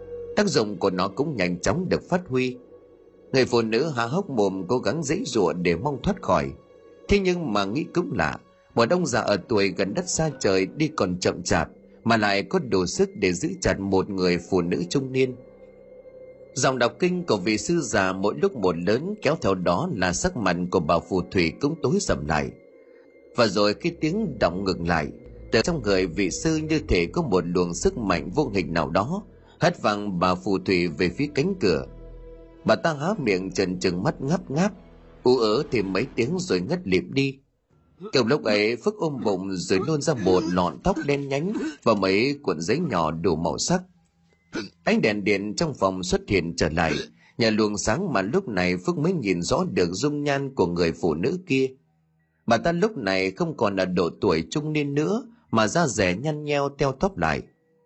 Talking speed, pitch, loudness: 210 wpm, 130 Hz, -24 LUFS